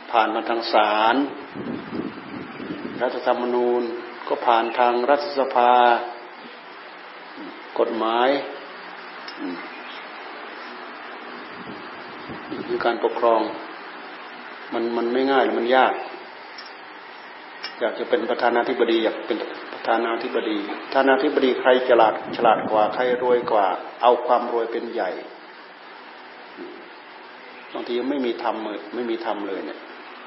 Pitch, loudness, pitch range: 120 Hz, -22 LUFS, 115-130 Hz